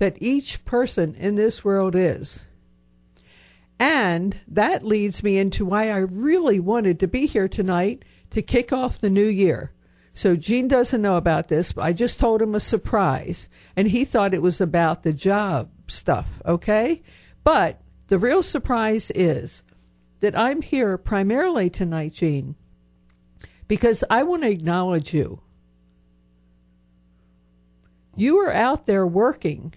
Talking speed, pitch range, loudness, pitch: 145 wpm, 140-220 Hz, -21 LUFS, 190 Hz